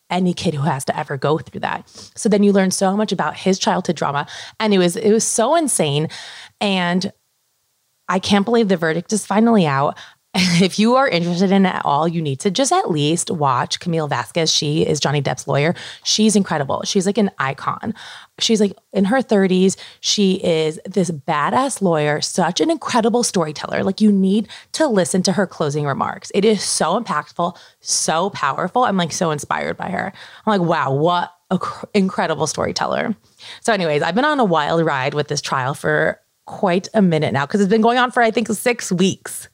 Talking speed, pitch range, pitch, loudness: 200 wpm, 160-215 Hz, 185 Hz, -18 LUFS